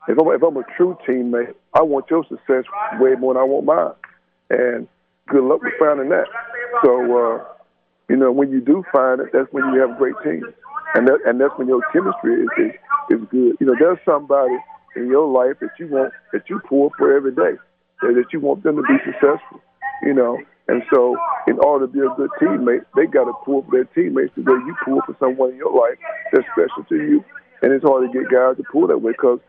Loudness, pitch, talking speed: -17 LUFS, 175 Hz, 235 wpm